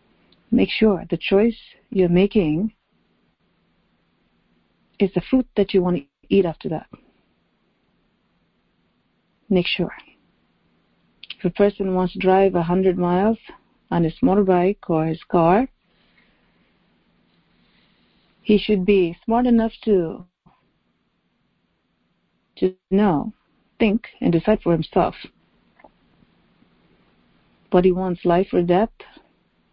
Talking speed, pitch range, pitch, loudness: 105 wpm, 175-210 Hz, 185 Hz, -20 LUFS